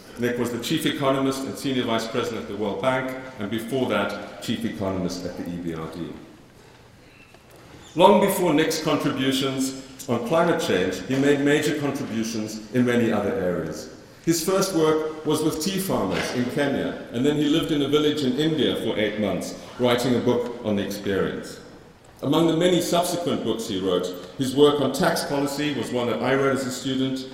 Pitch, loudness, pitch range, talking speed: 130 Hz, -23 LUFS, 110-150 Hz, 180 wpm